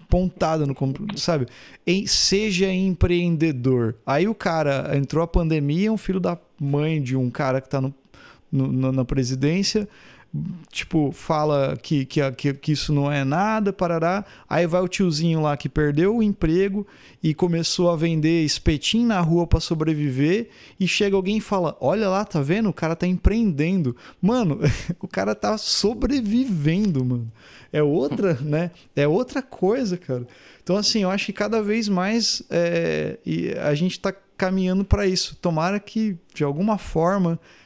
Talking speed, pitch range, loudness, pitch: 160 wpm, 145-195 Hz, -22 LUFS, 170 Hz